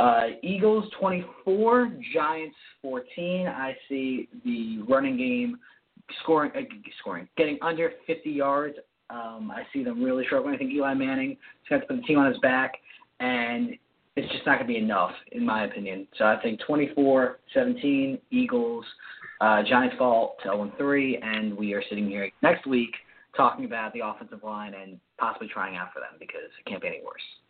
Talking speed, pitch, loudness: 175 wpm, 160 Hz, -27 LUFS